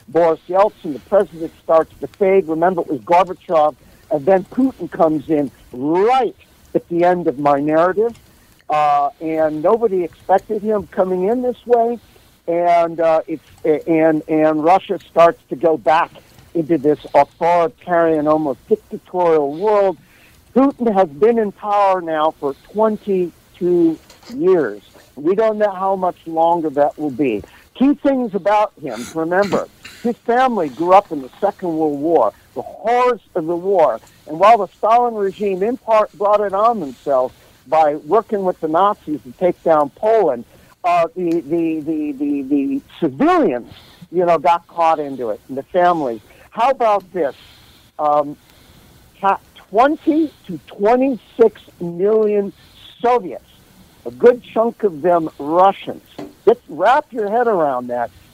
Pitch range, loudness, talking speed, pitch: 160-225 Hz, -17 LUFS, 145 wpm, 185 Hz